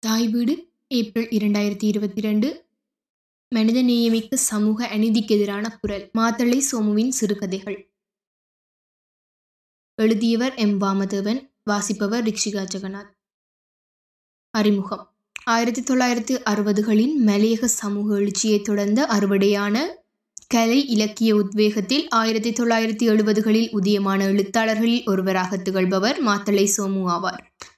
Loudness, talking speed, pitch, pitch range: -21 LUFS, 95 wpm, 215 Hz, 205-230 Hz